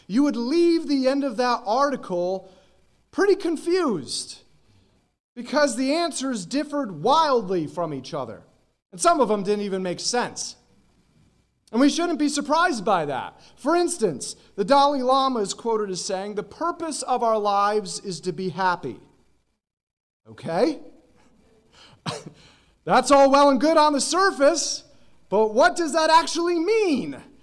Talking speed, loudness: 145 wpm, -22 LUFS